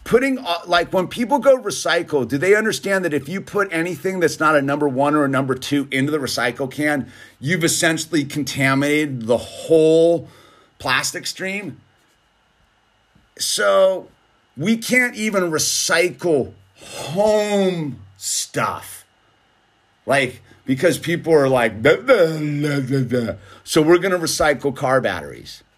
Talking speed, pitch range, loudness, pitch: 135 wpm, 135-185 Hz, -19 LUFS, 155 Hz